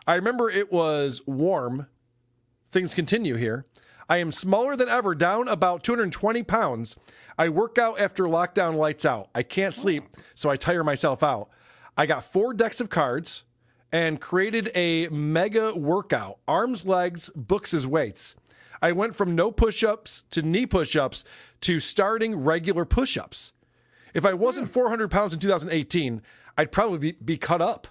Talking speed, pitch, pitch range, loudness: 155 wpm, 175 Hz, 150-210 Hz, -24 LUFS